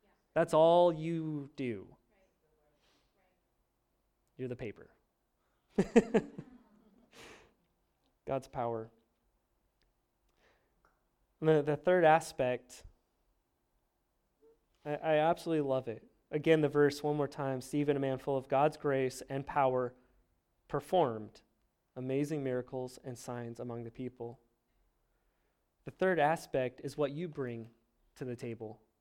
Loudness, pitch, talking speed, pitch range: -33 LUFS, 135 Hz, 105 wpm, 120-155 Hz